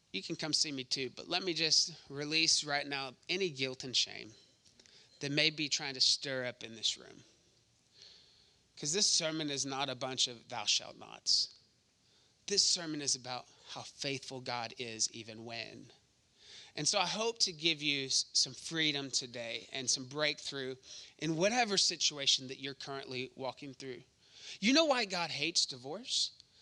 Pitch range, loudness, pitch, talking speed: 125-160 Hz, -33 LUFS, 140 Hz, 170 wpm